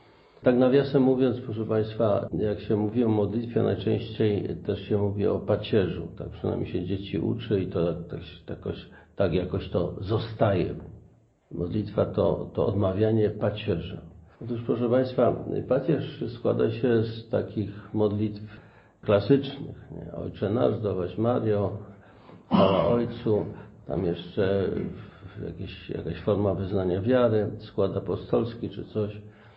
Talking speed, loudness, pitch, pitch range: 125 wpm, -27 LUFS, 105 Hz, 95-115 Hz